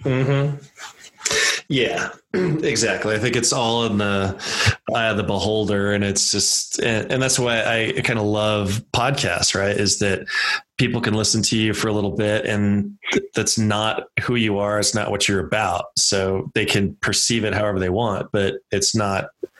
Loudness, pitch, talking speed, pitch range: -20 LUFS, 105 Hz, 185 wpm, 100-120 Hz